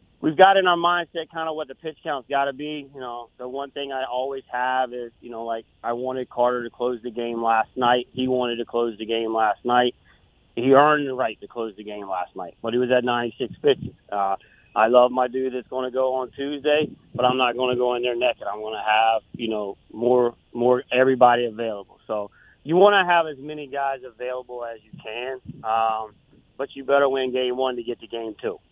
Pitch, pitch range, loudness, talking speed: 125 Hz, 115-135 Hz, -23 LUFS, 235 wpm